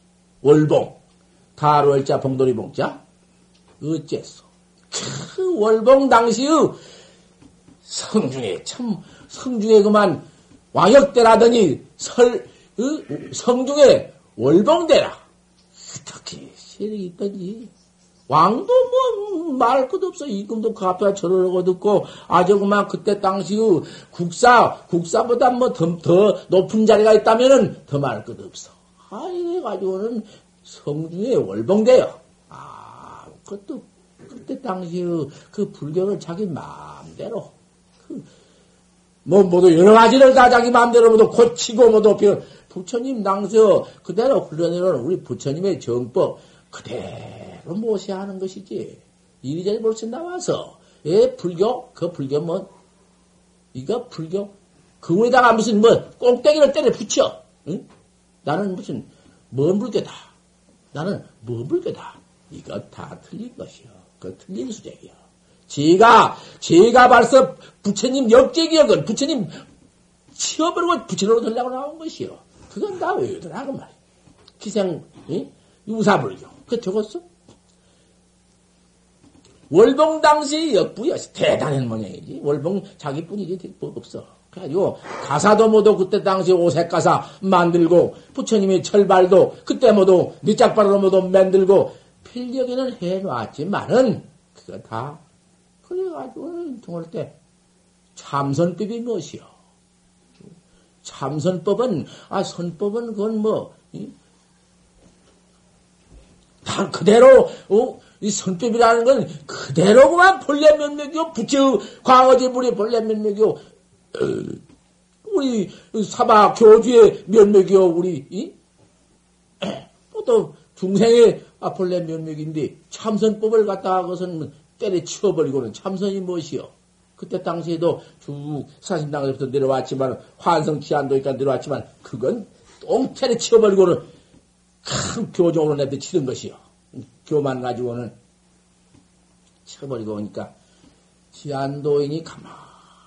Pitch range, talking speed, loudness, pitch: 170-240 Hz, 240 characters per minute, -17 LUFS, 200 Hz